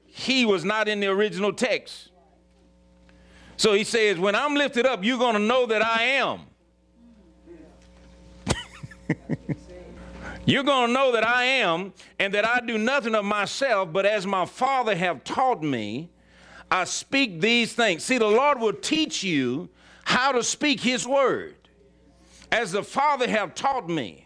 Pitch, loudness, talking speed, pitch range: 215 Hz, -23 LUFS, 155 wpm, 170-250 Hz